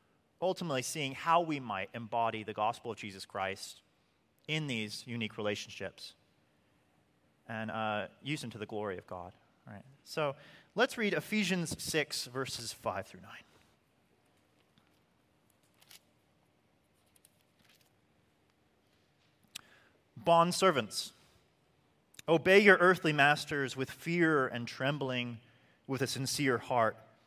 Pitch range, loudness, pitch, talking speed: 110-150 Hz, -32 LUFS, 125 Hz, 105 wpm